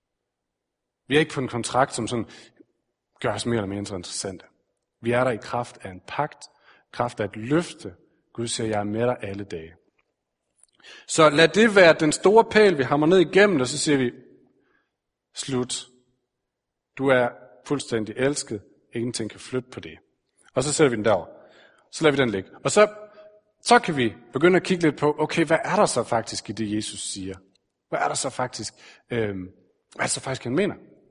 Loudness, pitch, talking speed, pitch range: -23 LUFS, 125 Hz, 200 wpm, 105-150 Hz